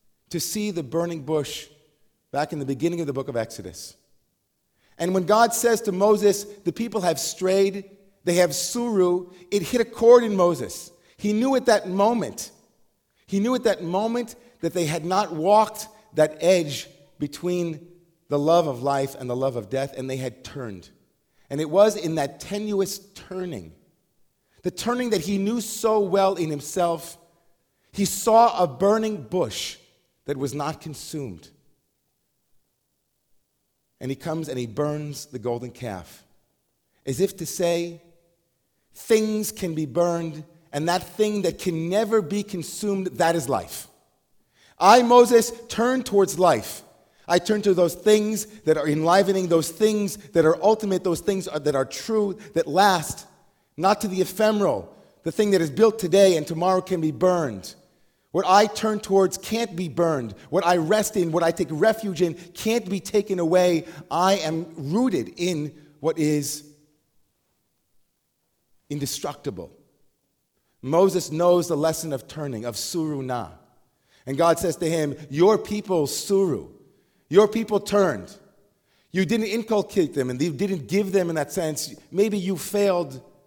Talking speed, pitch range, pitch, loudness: 160 wpm, 155-205 Hz, 175 Hz, -23 LUFS